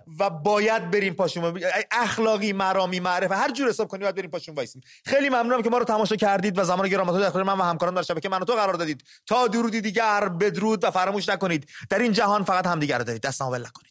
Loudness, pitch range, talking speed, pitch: -24 LUFS, 175-215 Hz, 230 wpm, 195 Hz